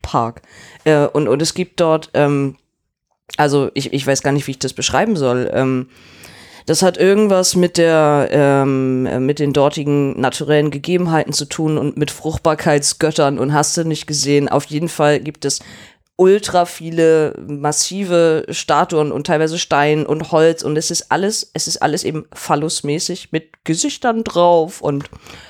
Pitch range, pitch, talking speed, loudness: 140-165 Hz, 150 Hz, 160 wpm, -16 LUFS